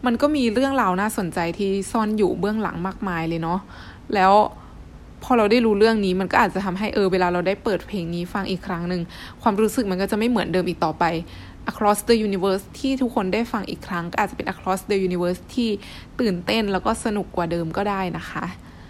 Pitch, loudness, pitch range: 195 Hz, -22 LUFS, 180-220 Hz